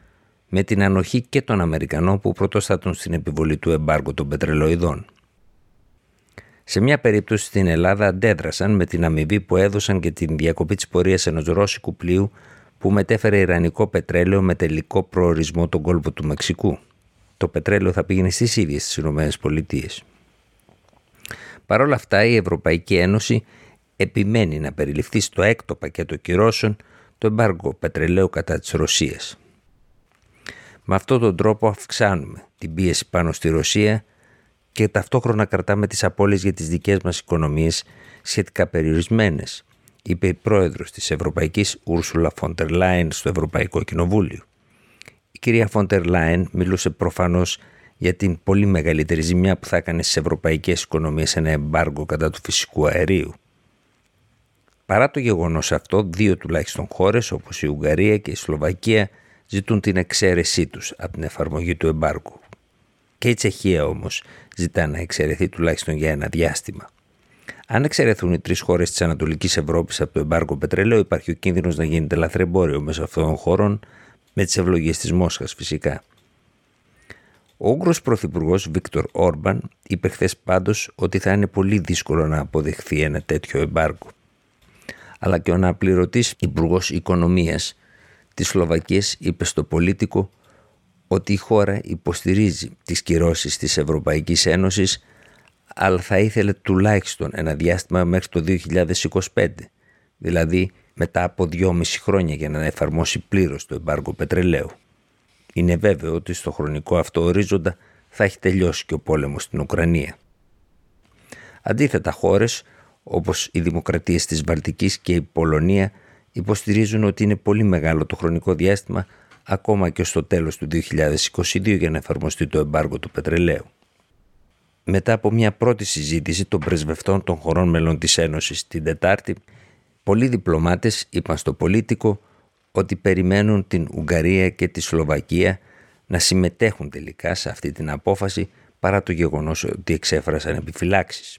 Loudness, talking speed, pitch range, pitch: -20 LUFS, 140 wpm, 80-100 Hz, 90 Hz